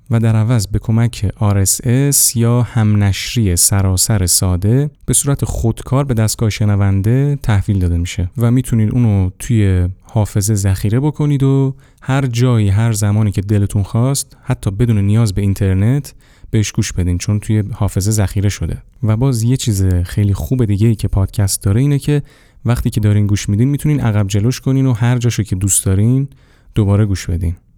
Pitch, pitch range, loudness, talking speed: 110 Hz, 100-125 Hz, -15 LUFS, 170 wpm